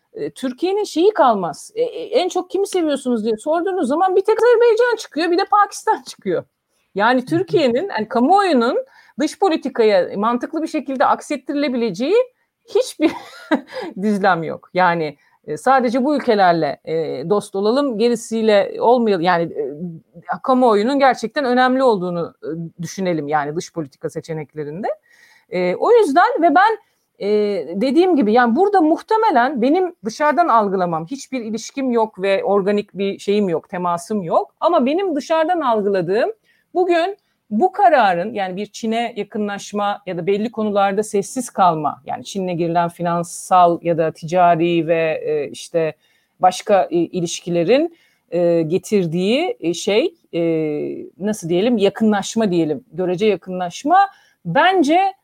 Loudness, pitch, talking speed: -18 LUFS, 230 Hz, 120 wpm